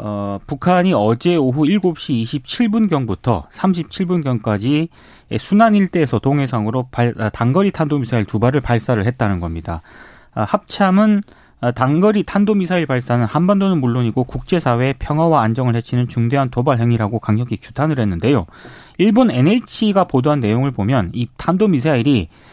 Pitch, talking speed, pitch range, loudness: 130 Hz, 330 characters per minute, 115-175 Hz, -17 LUFS